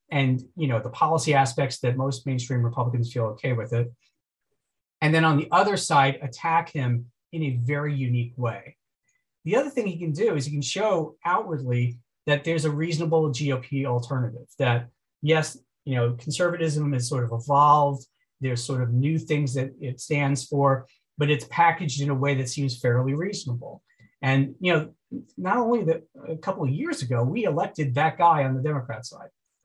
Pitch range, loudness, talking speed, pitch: 125-155 Hz, -25 LUFS, 185 wpm, 140 Hz